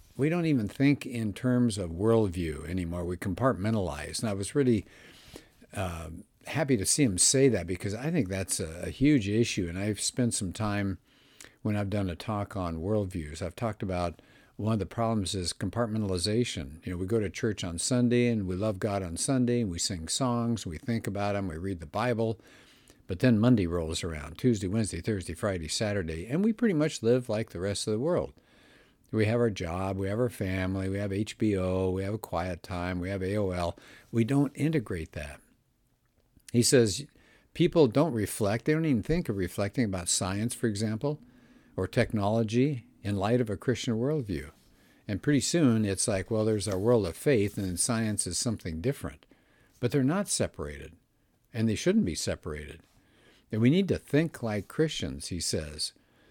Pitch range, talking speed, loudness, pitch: 95-120 Hz, 190 wpm, -29 LUFS, 105 Hz